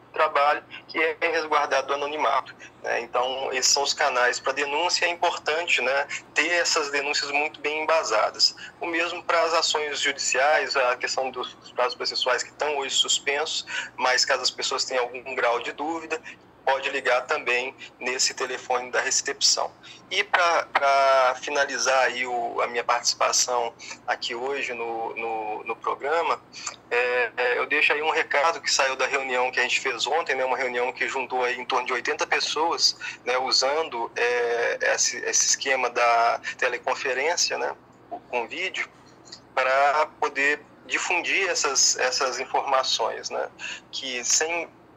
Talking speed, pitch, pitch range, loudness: 150 wpm, 135 Hz, 125-155 Hz, -23 LUFS